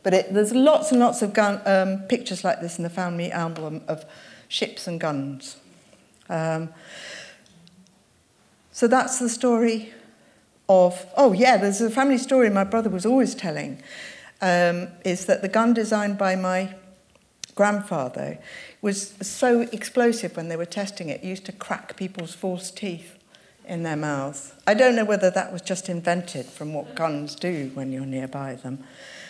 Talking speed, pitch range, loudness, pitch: 165 wpm, 170-220 Hz, -23 LUFS, 190 Hz